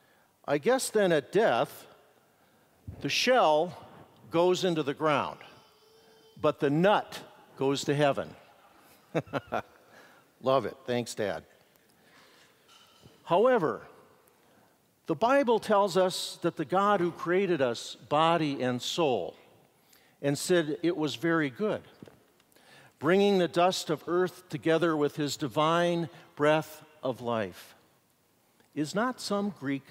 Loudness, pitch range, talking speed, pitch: -28 LUFS, 145-185 Hz, 115 wpm, 165 Hz